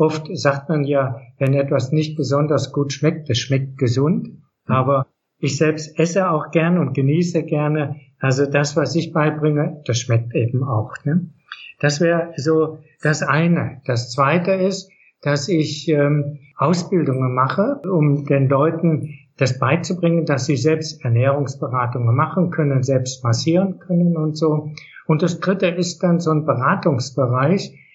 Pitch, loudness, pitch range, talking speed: 150 Hz, -19 LUFS, 135-165 Hz, 150 wpm